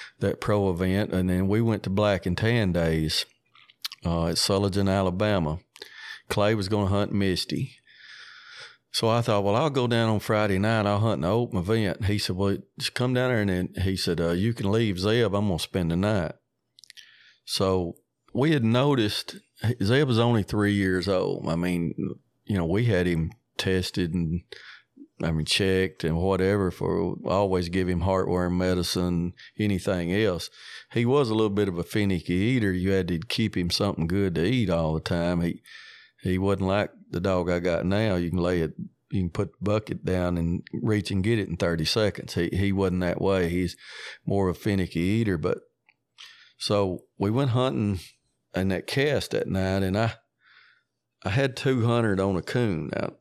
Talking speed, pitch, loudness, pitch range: 190 wpm, 95 Hz, -26 LUFS, 90-105 Hz